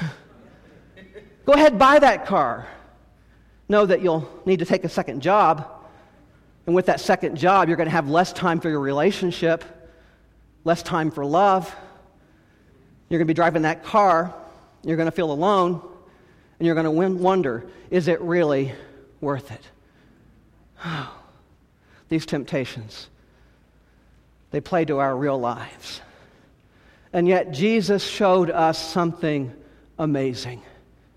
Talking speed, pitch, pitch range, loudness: 135 wpm, 165 Hz, 145-180 Hz, -21 LUFS